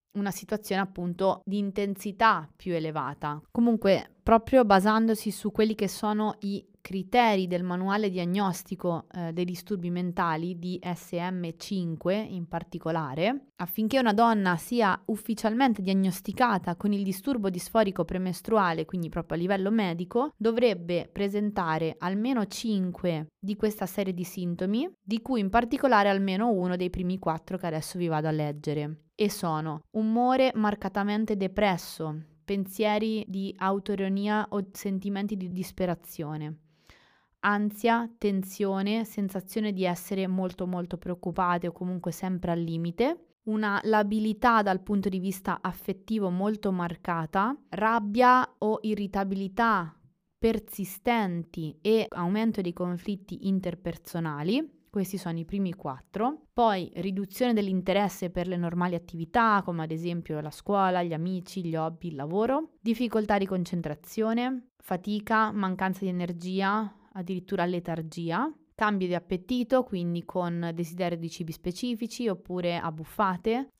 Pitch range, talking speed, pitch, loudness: 175-215 Hz, 125 wpm, 195 Hz, -29 LUFS